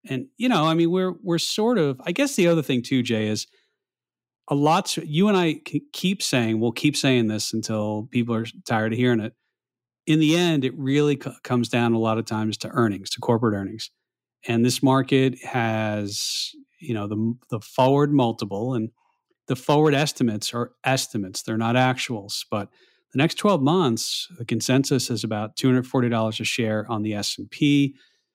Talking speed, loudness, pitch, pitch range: 195 wpm, -23 LUFS, 125 Hz, 110-150 Hz